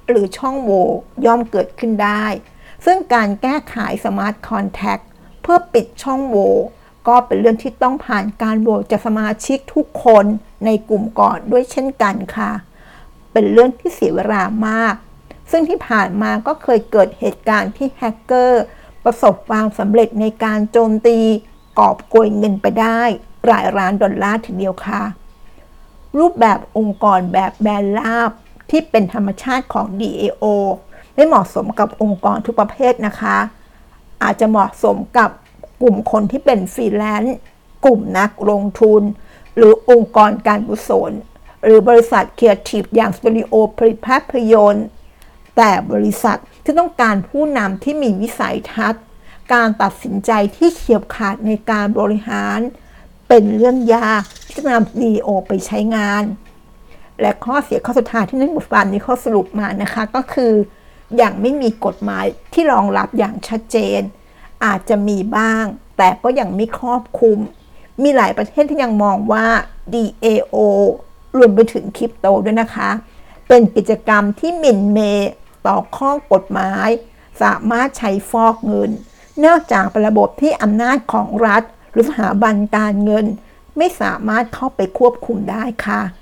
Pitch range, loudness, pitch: 210-240 Hz, -15 LUFS, 220 Hz